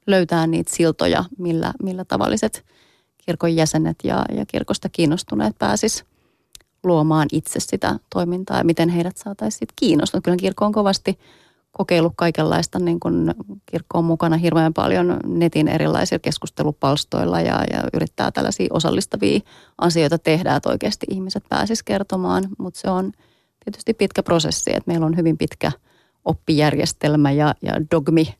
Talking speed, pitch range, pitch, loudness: 135 wpm, 155-185 Hz, 165 Hz, -20 LUFS